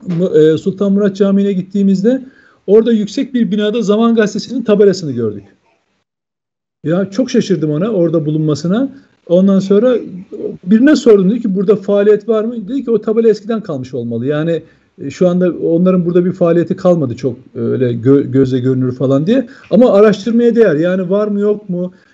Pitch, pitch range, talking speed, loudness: 195 Hz, 165-220 Hz, 165 wpm, -13 LUFS